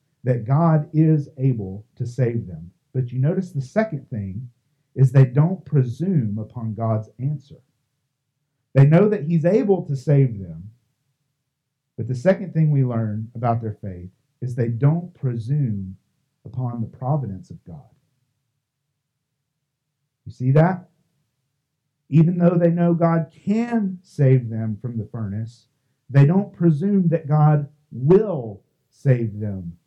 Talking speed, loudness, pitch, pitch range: 135 wpm, -21 LUFS, 135 Hz, 120-155 Hz